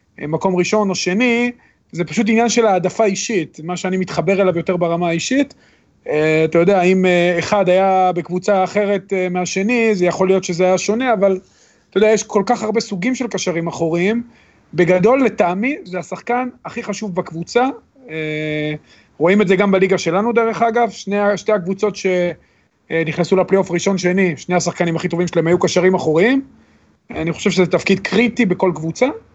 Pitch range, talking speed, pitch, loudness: 175-215 Hz, 170 wpm, 190 Hz, -17 LUFS